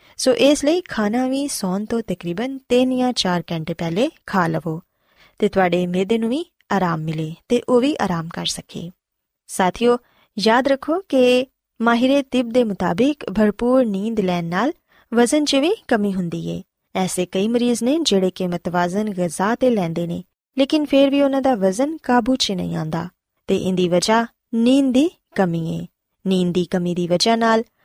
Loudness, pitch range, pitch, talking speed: -19 LUFS, 180-255 Hz, 220 Hz, 170 wpm